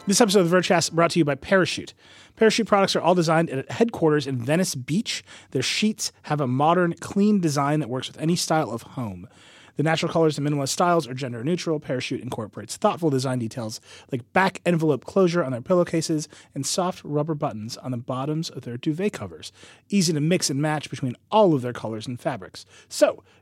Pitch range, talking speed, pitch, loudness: 130-180 Hz, 200 wpm, 155 Hz, -23 LUFS